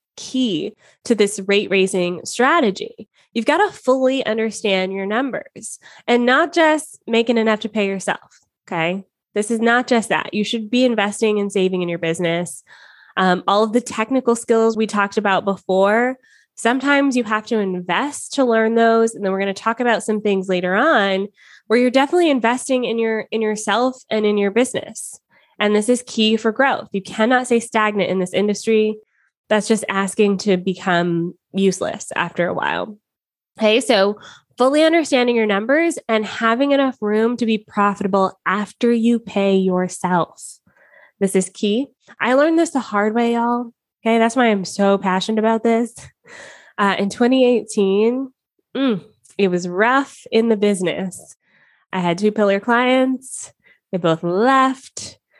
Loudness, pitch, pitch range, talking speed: -18 LUFS, 220 Hz, 195-245 Hz, 165 wpm